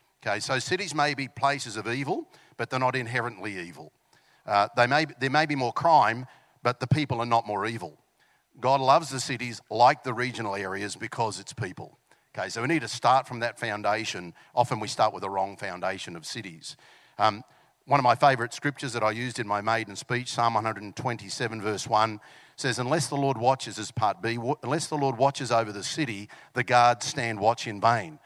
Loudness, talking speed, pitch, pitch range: -27 LUFS, 210 wpm, 120 Hz, 110-135 Hz